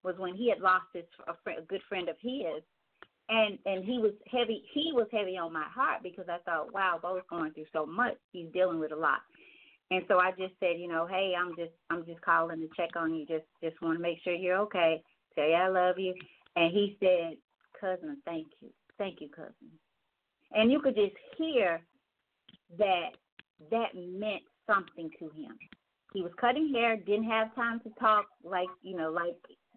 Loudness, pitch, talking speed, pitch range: -32 LUFS, 185 Hz, 205 wpm, 170-215 Hz